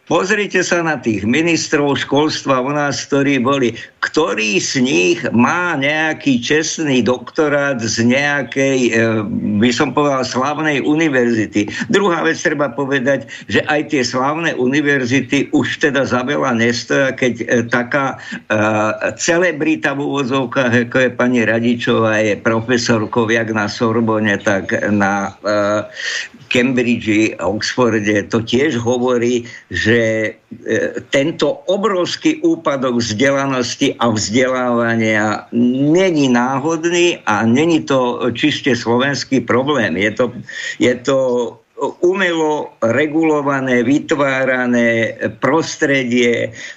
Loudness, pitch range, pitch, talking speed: -15 LUFS, 115-150 Hz, 125 Hz, 110 wpm